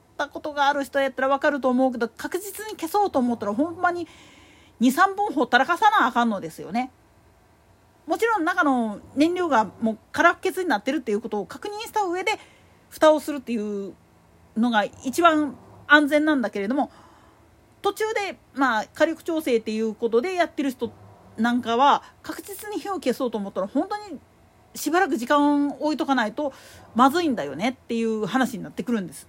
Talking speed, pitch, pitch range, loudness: 375 characters per minute, 280 Hz, 235-340 Hz, -23 LUFS